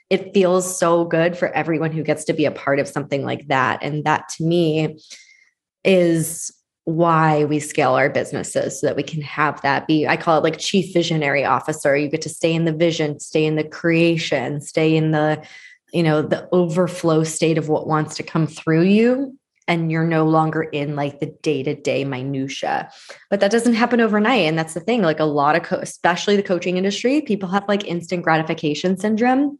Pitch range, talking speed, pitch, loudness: 155-180 Hz, 205 wpm, 160 Hz, -19 LUFS